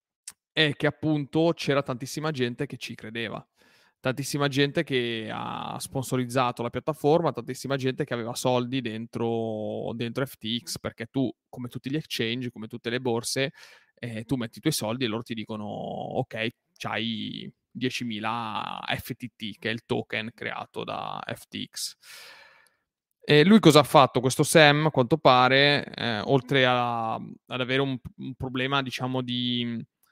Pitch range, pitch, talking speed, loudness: 115-140 Hz, 125 Hz, 145 wpm, -26 LUFS